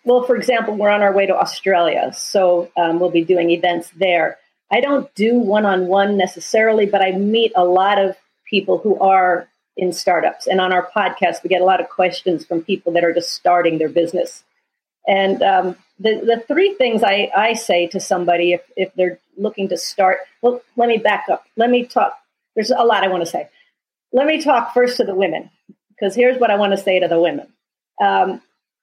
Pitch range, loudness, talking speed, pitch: 180-230 Hz, -17 LUFS, 210 wpm, 195 Hz